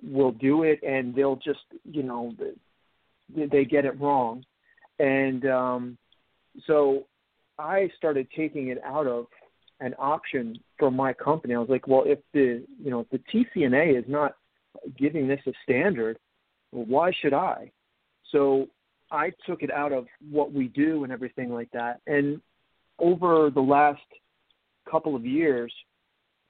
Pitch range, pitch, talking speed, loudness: 130-150 Hz, 140 Hz, 150 wpm, -26 LUFS